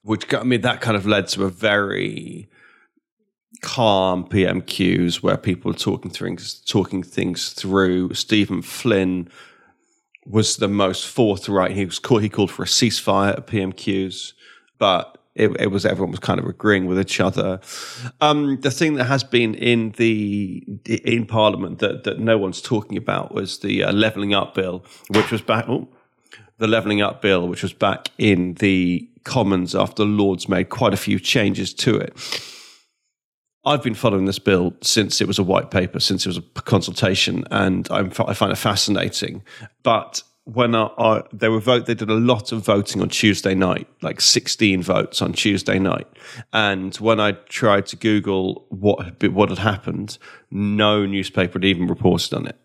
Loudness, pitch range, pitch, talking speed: -20 LUFS, 95-115 Hz, 105 Hz, 175 wpm